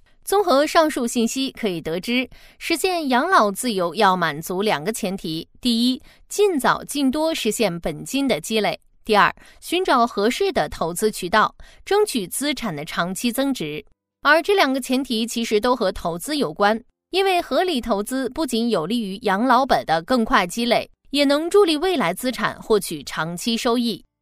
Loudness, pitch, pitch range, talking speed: -21 LUFS, 235 Hz, 200-285 Hz, 255 characters per minute